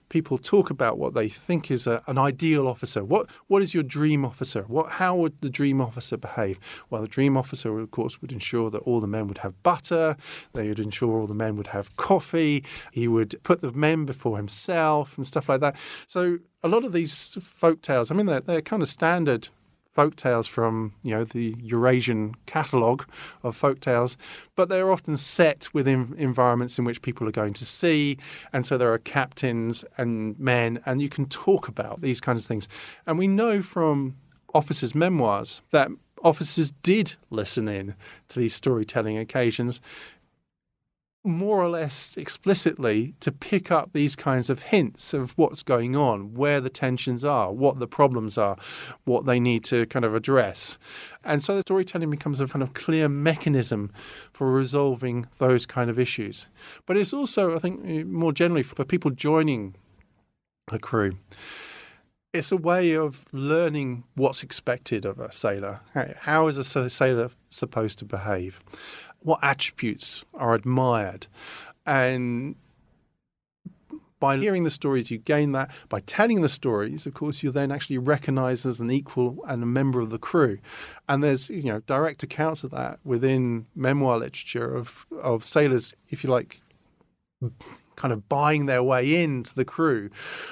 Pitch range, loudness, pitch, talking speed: 120-155 Hz, -25 LUFS, 135 Hz, 170 wpm